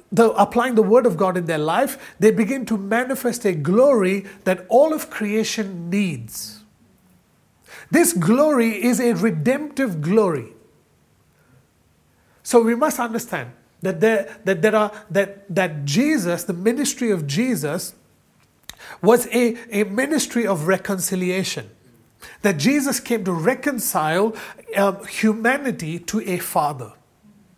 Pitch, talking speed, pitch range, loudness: 205 Hz, 125 wpm, 180-235 Hz, -20 LUFS